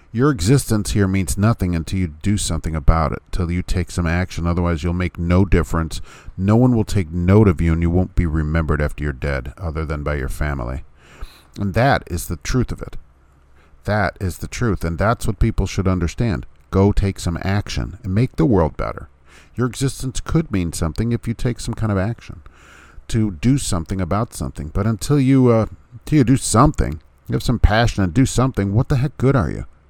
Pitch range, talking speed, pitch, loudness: 80-115 Hz, 210 wpm, 95 Hz, -19 LUFS